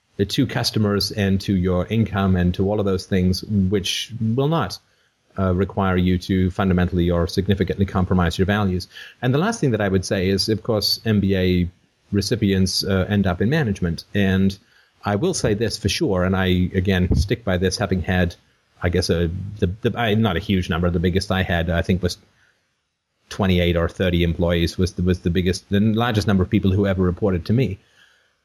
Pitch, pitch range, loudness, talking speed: 95 Hz, 90-105 Hz, -21 LUFS, 200 wpm